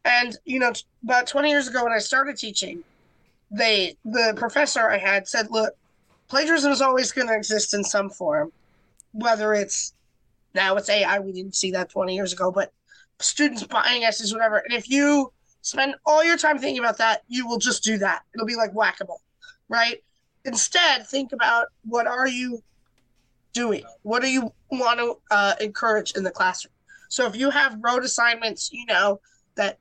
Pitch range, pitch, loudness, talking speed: 210-270 Hz, 235 Hz, -22 LUFS, 185 wpm